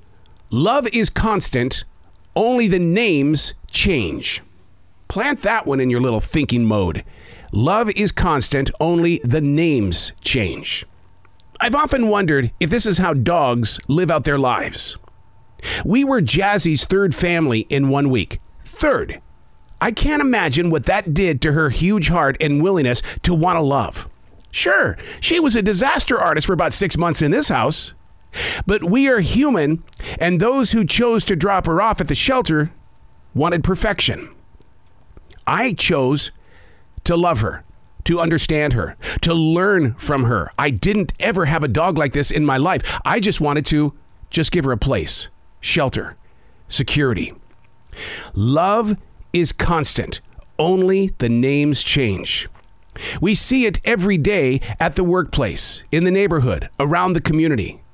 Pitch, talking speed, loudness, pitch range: 150 Hz, 150 wpm, -17 LUFS, 120-185 Hz